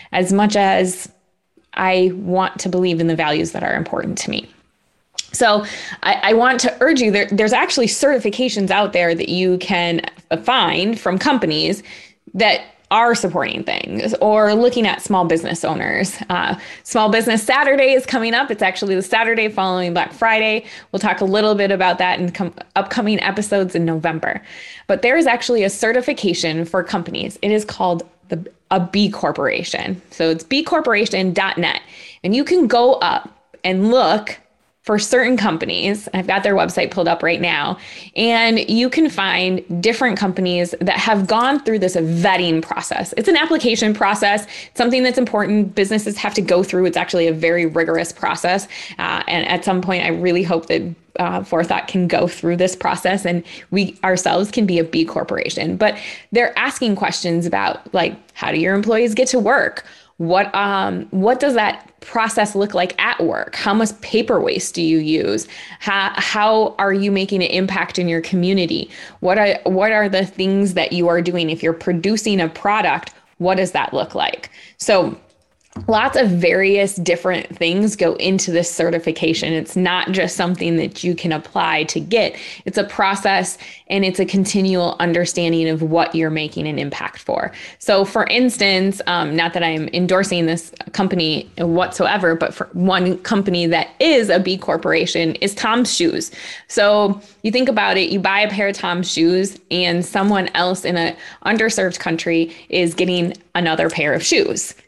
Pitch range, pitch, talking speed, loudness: 175-215 Hz, 190 Hz, 175 wpm, -17 LUFS